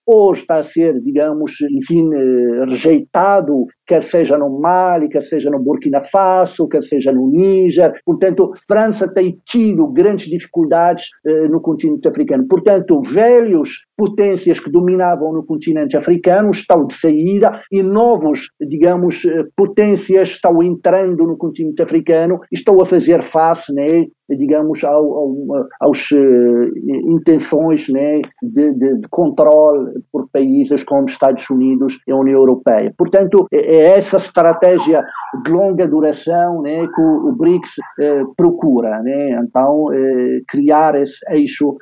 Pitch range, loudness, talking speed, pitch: 145-190 Hz, -13 LUFS, 135 wpm, 165 Hz